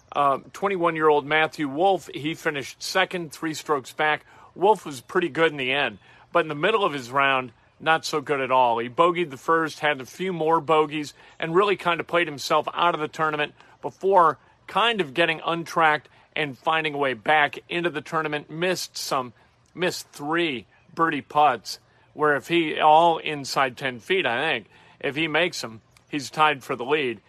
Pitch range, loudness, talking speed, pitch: 140-170 Hz, -23 LUFS, 190 wpm, 155 Hz